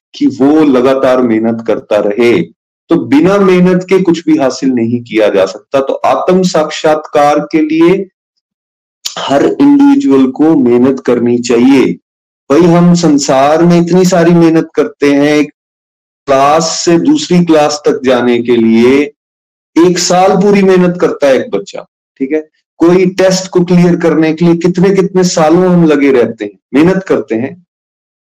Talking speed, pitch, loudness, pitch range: 155 wpm, 160 Hz, -9 LUFS, 135-180 Hz